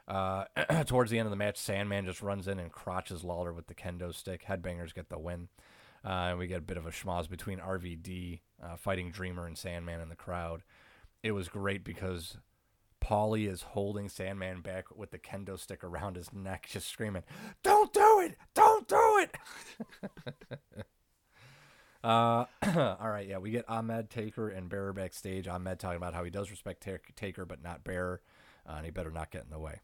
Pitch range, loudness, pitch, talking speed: 90-105 Hz, -34 LUFS, 95 Hz, 195 wpm